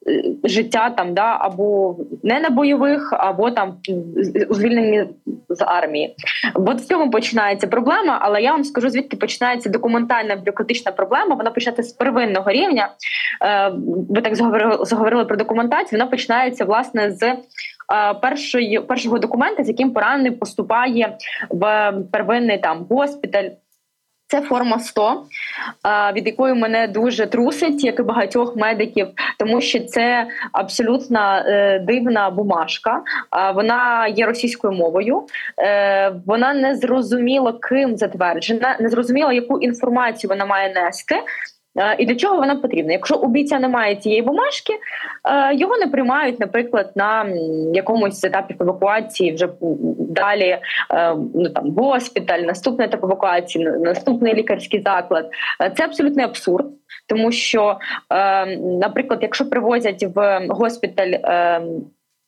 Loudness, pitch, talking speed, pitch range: -18 LUFS, 225 Hz, 120 wpm, 200-255 Hz